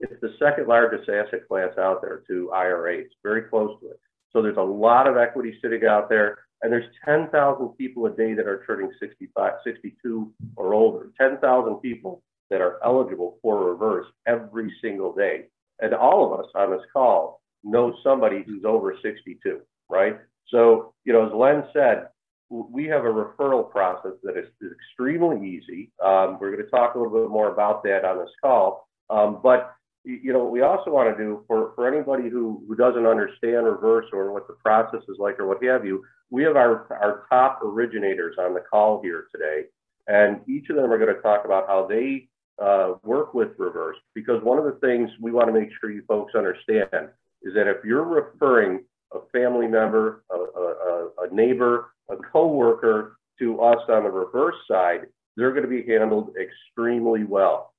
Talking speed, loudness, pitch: 190 wpm, -22 LUFS, 120 Hz